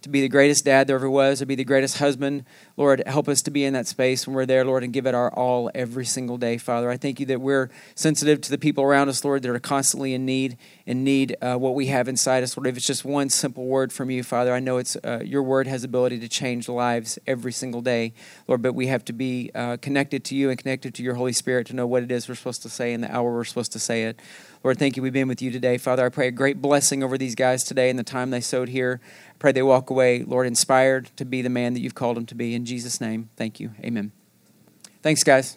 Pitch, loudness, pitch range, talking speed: 130 Hz, -23 LUFS, 125-135 Hz, 275 wpm